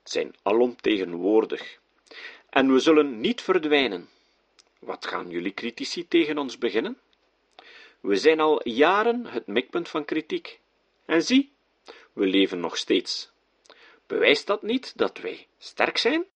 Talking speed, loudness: 130 wpm, -24 LUFS